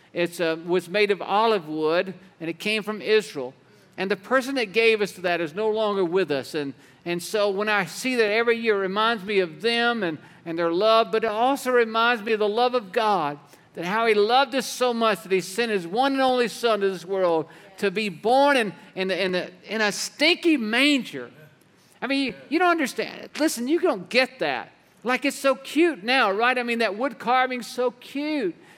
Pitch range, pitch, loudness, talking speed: 190-250 Hz, 220 Hz, -23 LUFS, 220 wpm